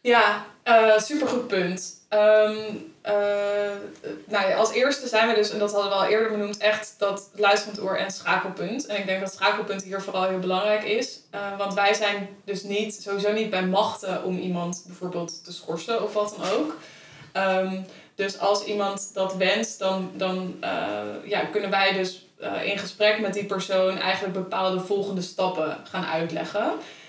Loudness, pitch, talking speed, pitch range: -25 LUFS, 200 Hz, 185 wpm, 190-210 Hz